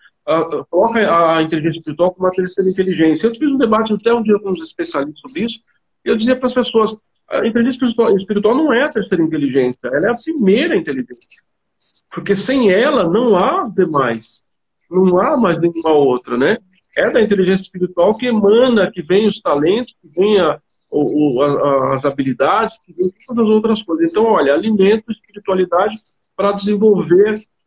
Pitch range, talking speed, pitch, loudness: 165-220 Hz, 180 wpm, 195 Hz, -15 LUFS